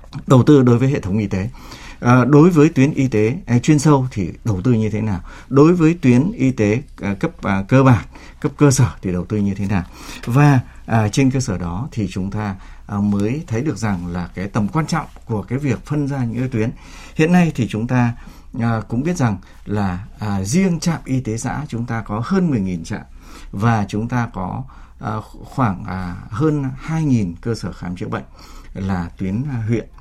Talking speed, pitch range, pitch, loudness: 195 wpm, 100-135 Hz, 115 Hz, -18 LUFS